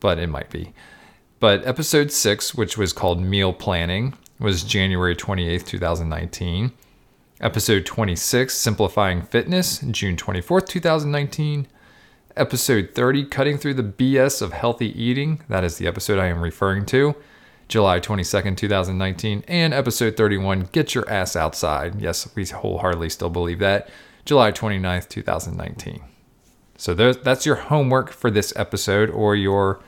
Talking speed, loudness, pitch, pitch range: 135 wpm, -21 LUFS, 105 Hz, 95-130 Hz